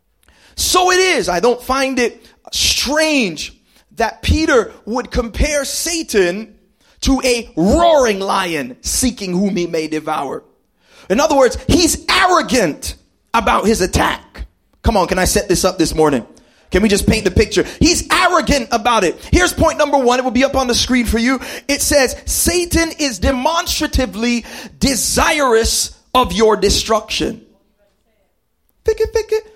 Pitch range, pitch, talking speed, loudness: 220-315 Hz, 255 Hz, 150 wpm, -15 LUFS